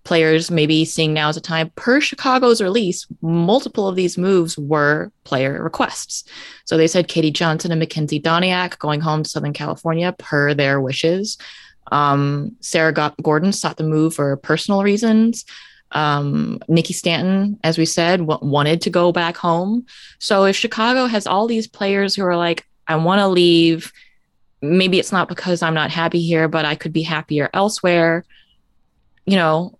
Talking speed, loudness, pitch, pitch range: 170 wpm, -17 LUFS, 165 Hz, 155-185 Hz